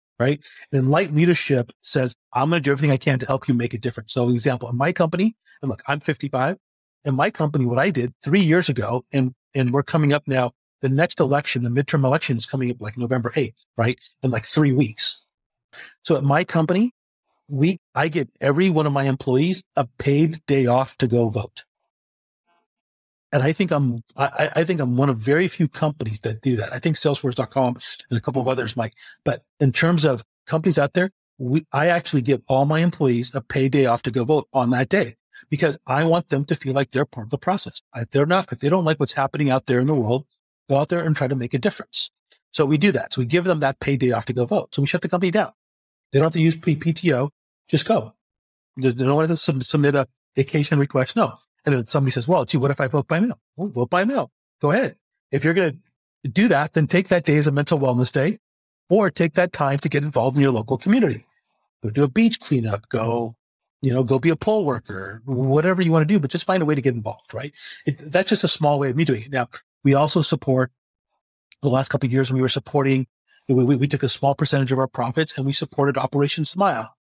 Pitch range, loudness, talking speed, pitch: 130-160 Hz, -21 LUFS, 240 wpm, 140 Hz